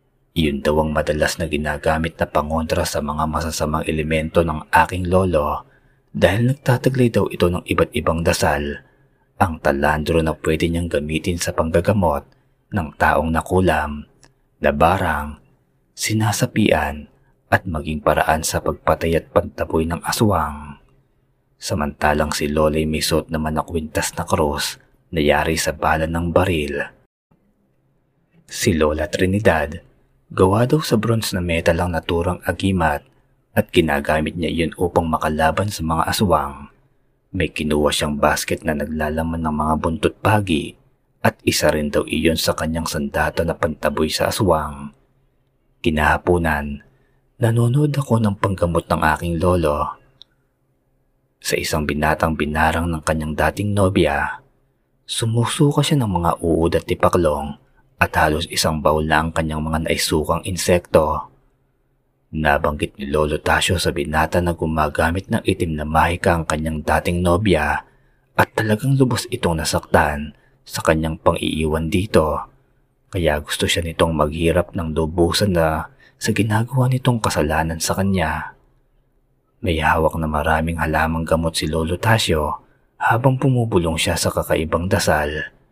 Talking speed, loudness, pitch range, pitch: 135 wpm, -19 LUFS, 75-90 Hz, 80 Hz